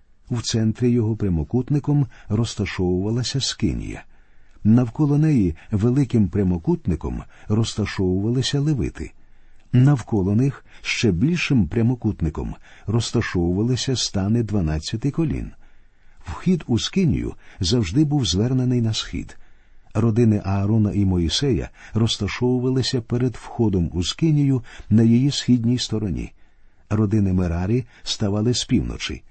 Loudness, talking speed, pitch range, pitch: -21 LUFS, 95 wpm, 100-125 Hz, 110 Hz